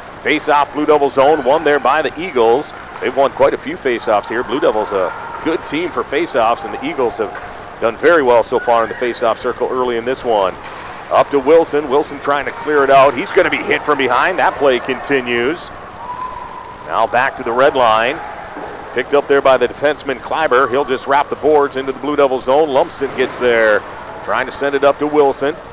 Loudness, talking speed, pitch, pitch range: -15 LUFS, 225 wpm, 145 Hz, 135-150 Hz